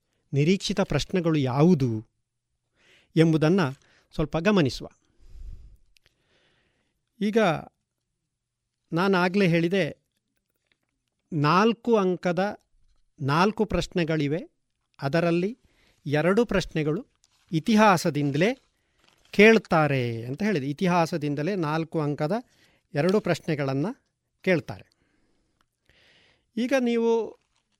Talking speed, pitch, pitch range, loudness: 65 wpm, 170 Hz, 150-200 Hz, -24 LUFS